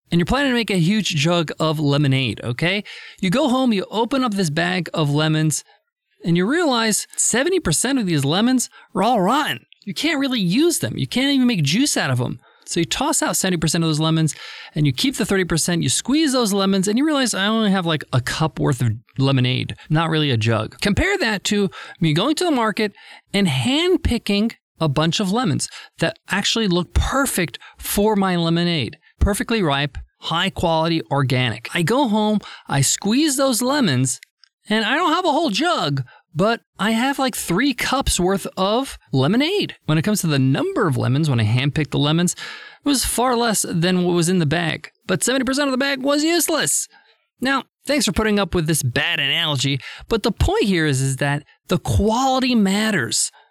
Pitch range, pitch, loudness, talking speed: 155-250 Hz, 190 Hz, -19 LUFS, 195 wpm